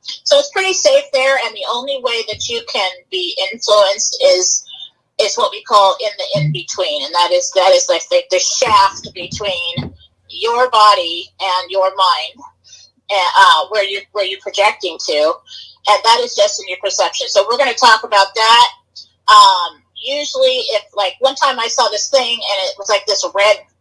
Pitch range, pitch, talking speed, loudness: 195-285 Hz, 230 Hz, 185 wpm, -13 LUFS